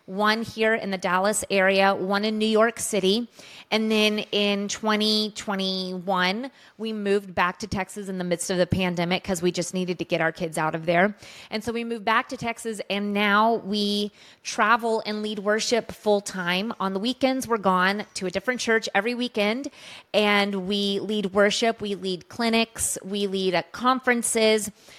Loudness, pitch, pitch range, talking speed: -24 LUFS, 205 Hz, 190-220 Hz, 180 wpm